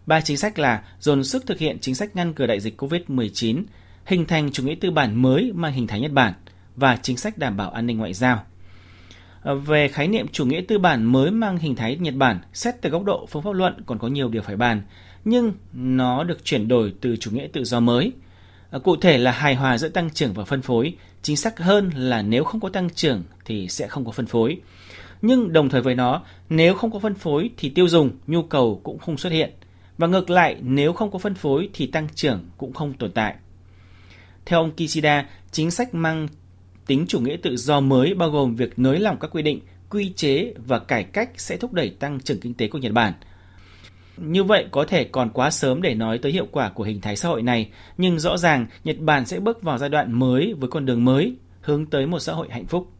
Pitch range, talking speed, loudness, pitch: 115-165 Hz, 235 wpm, -22 LUFS, 135 Hz